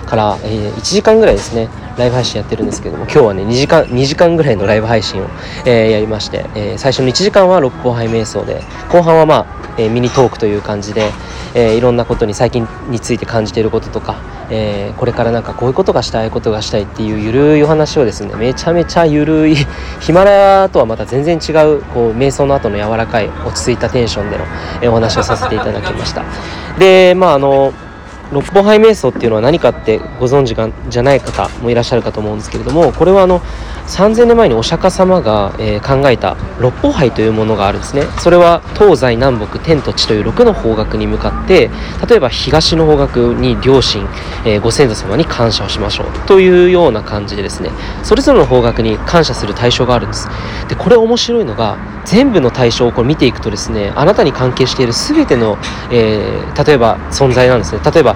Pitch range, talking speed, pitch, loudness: 110-150 Hz, 430 characters per minute, 120 Hz, -11 LUFS